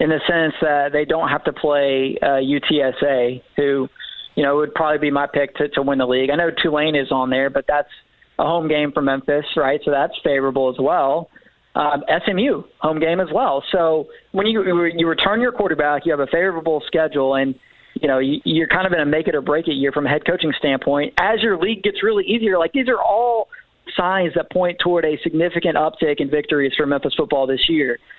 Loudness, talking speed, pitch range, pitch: -19 LUFS, 220 wpm, 140-170 Hz, 150 Hz